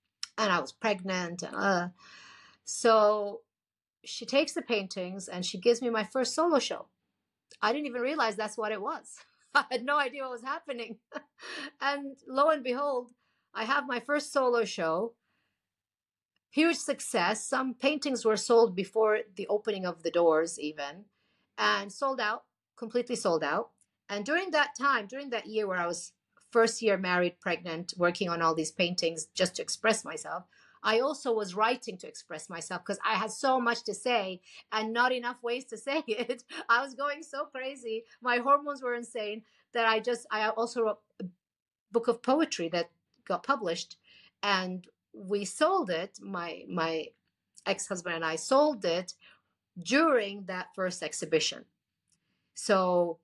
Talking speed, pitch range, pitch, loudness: 165 wpm, 185-260 Hz, 220 Hz, -30 LUFS